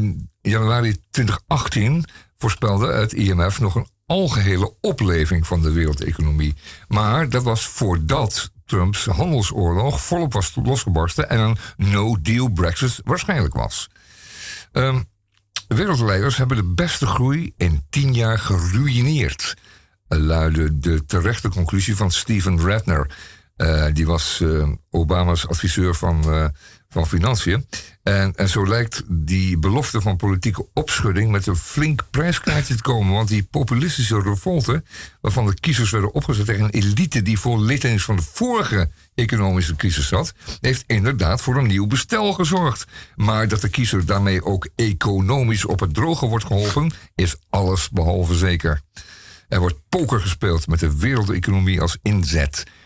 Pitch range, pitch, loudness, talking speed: 90-120 Hz, 100 Hz, -19 LUFS, 135 wpm